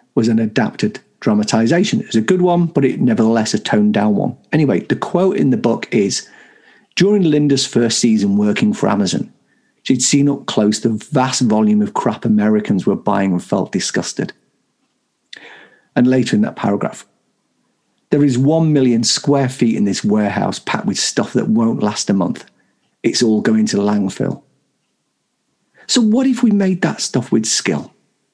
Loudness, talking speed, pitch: -16 LUFS, 170 wpm, 130 Hz